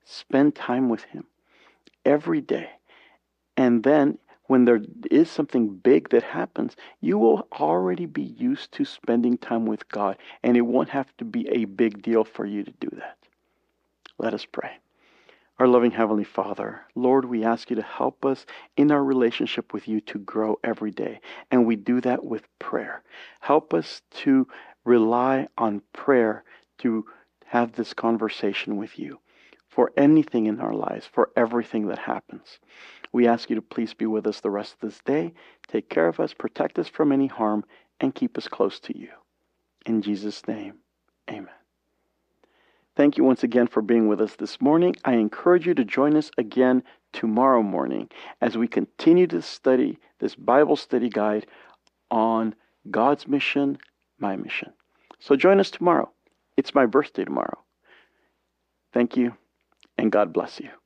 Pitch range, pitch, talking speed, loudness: 110-140 Hz, 120 Hz, 165 wpm, -23 LUFS